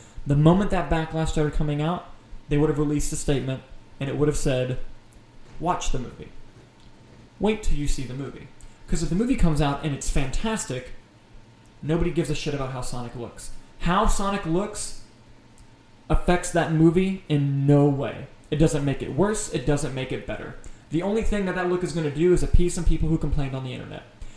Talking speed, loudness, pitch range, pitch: 200 wpm, -25 LUFS, 125-170 Hz, 150 Hz